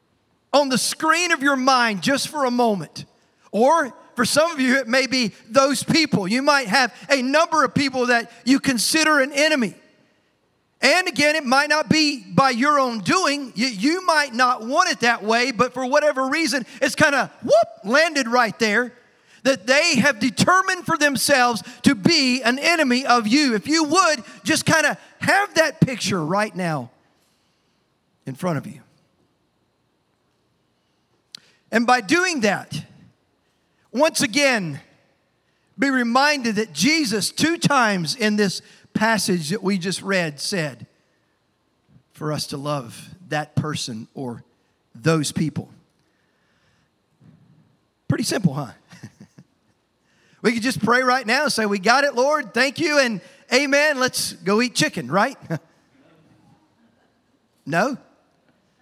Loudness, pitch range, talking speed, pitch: -19 LUFS, 210-285 Hz, 145 wpm, 250 Hz